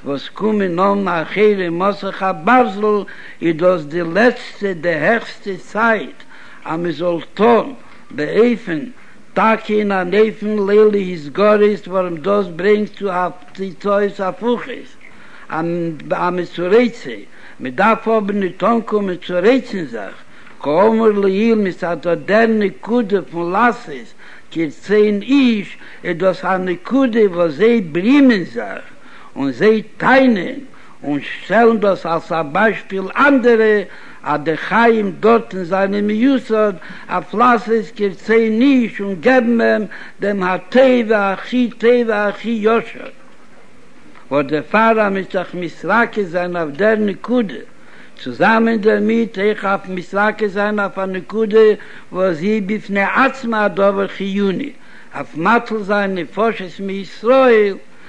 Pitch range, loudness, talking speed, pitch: 185-230 Hz, -16 LUFS, 140 wpm, 210 Hz